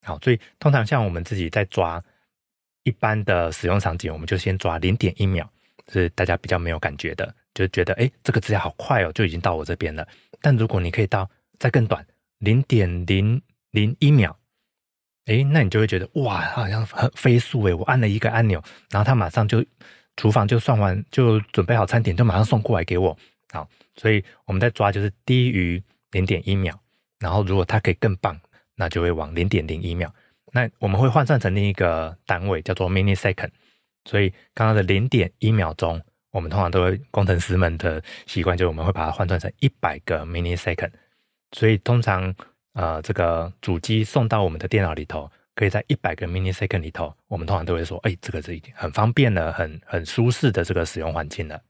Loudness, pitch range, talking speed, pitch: -22 LUFS, 90-115 Hz, 335 characters per minute, 100 Hz